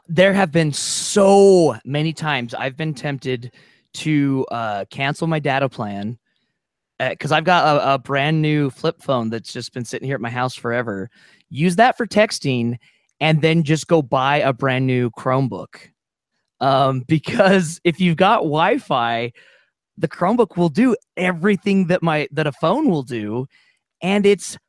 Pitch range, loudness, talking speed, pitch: 130-175 Hz, -18 LUFS, 165 wpm, 150 Hz